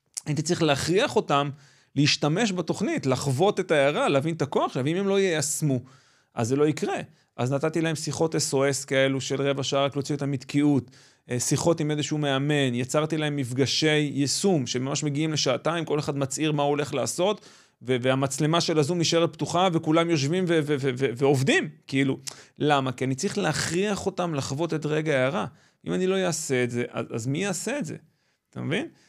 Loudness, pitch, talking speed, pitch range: -25 LUFS, 145 Hz, 180 wpm, 135-165 Hz